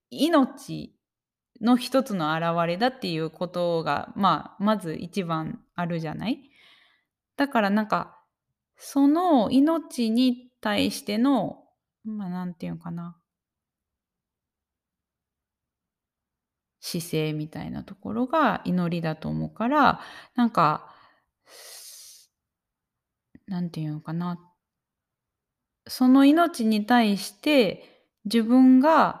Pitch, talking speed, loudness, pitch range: 200 Hz, 185 characters per minute, -24 LUFS, 165-255 Hz